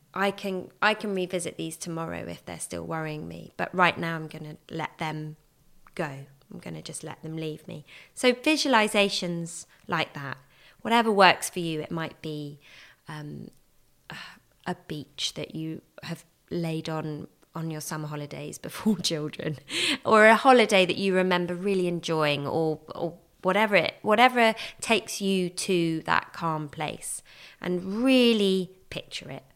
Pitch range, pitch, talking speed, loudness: 155-195 Hz, 170 Hz, 160 wpm, -26 LUFS